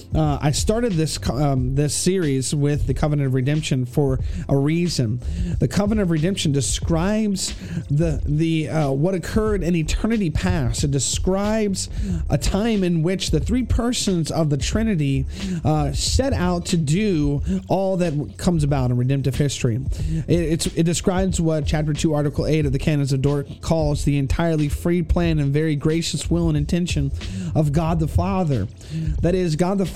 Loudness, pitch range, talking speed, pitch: -21 LUFS, 140-175 Hz, 170 wpm, 155 Hz